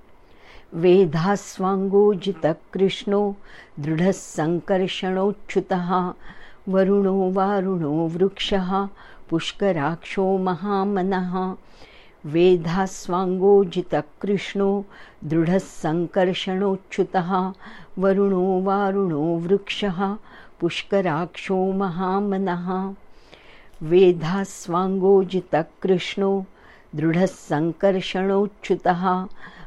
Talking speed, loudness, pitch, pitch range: 30 wpm, -22 LUFS, 190 Hz, 180-195 Hz